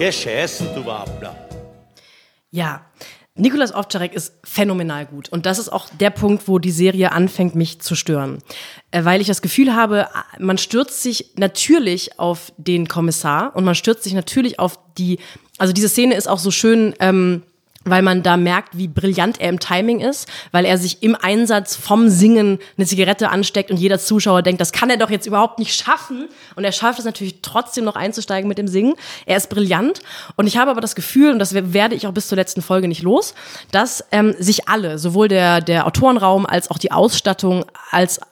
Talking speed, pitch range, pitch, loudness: 190 wpm, 180-215 Hz, 195 Hz, -17 LUFS